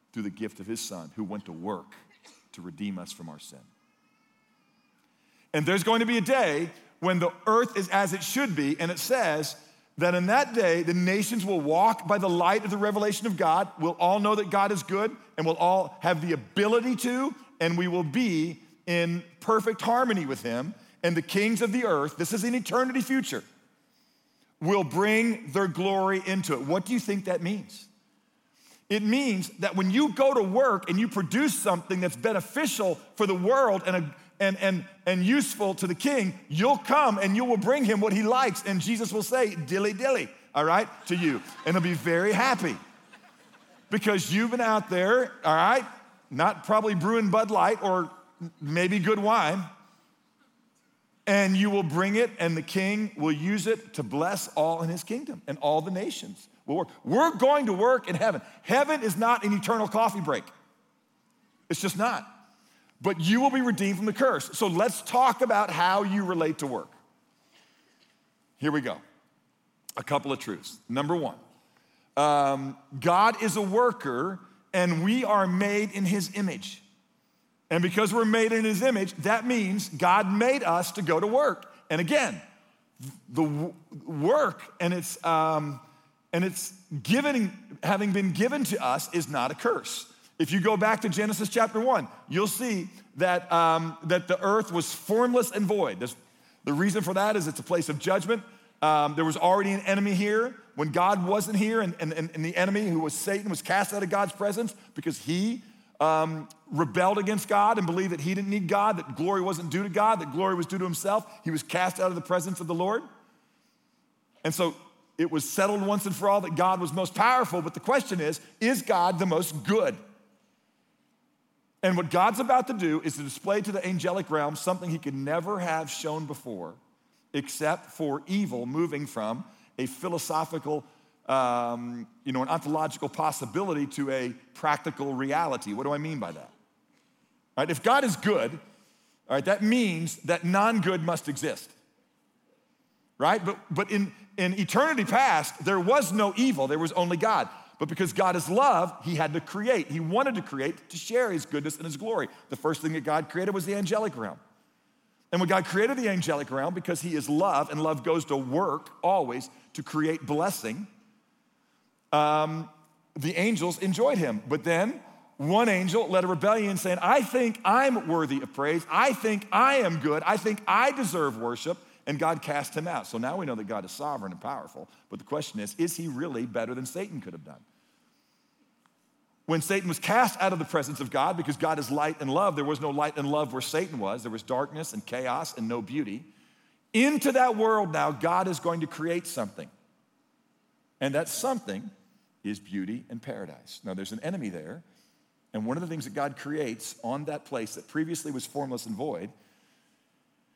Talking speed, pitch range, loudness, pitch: 190 wpm, 160-225 Hz, -27 LUFS, 190 Hz